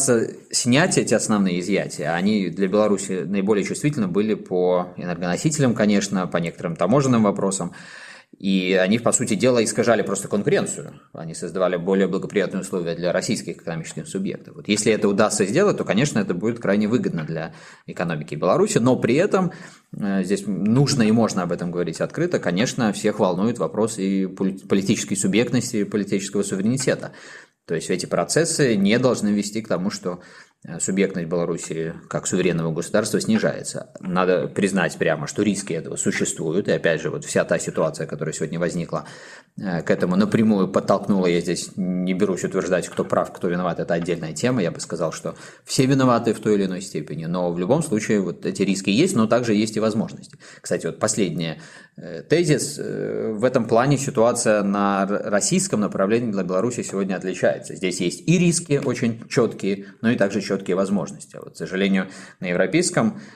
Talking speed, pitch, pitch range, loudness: 165 wpm, 105 Hz, 95-125 Hz, -22 LUFS